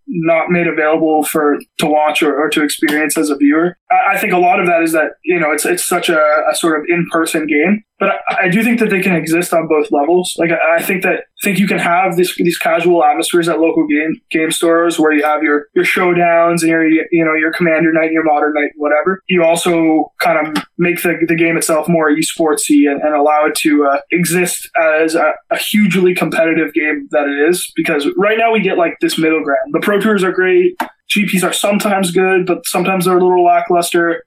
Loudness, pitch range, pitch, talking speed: -13 LUFS, 155-180 Hz, 170 Hz, 230 wpm